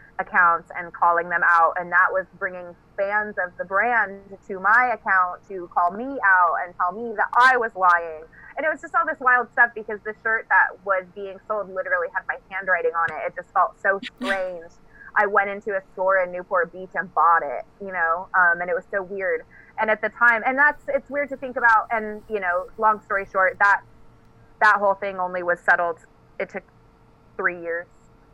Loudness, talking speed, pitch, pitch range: -21 LUFS, 210 wpm, 195 Hz, 175-220 Hz